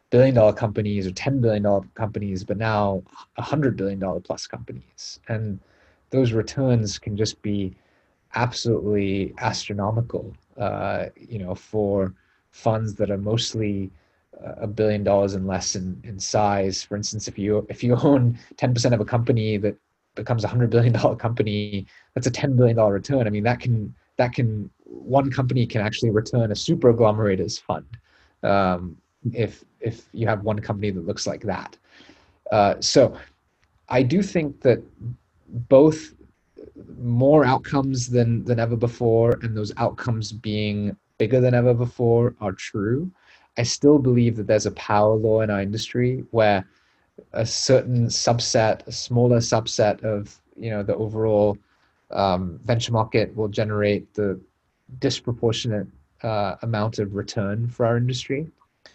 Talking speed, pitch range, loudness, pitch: 155 wpm, 105-120 Hz, -22 LUFS, 110 Hz